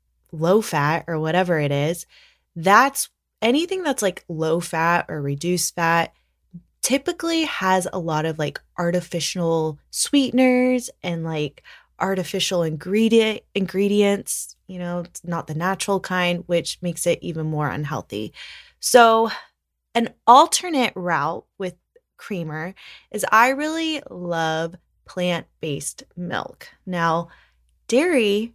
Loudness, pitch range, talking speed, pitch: -21 LUFS, 165-210 Hz, 120 wpm, 175 Hz